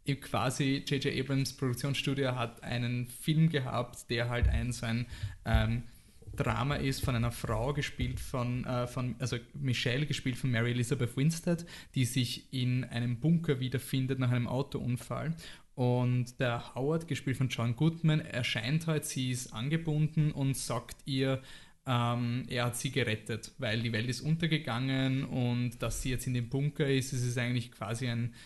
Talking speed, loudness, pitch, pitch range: 160 wpm, -33 LUFS, 125 Hz, 120-140 Hz